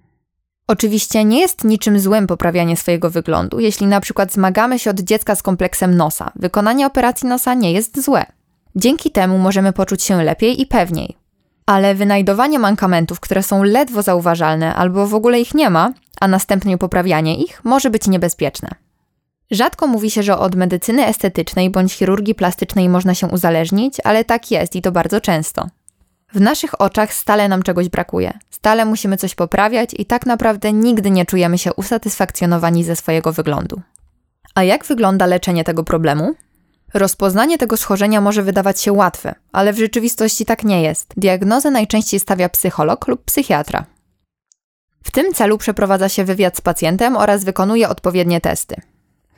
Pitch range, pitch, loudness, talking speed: 180-220 Hz, 200 Hz, -15 LUFS, 160 wpm